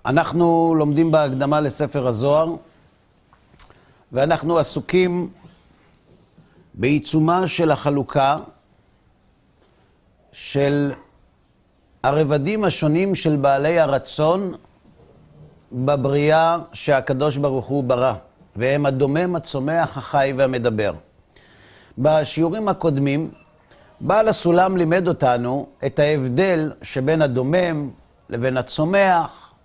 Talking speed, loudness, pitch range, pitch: 75 wpm, -19 LUFS, 135-165 Hz, 150 Hz